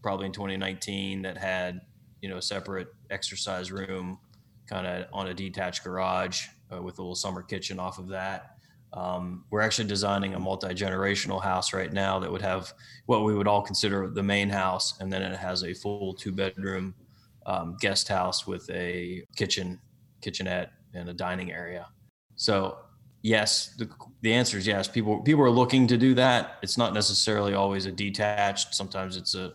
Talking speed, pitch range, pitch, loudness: 175 wpm, 95-105 Hz, 95 Hz, -28 LUFS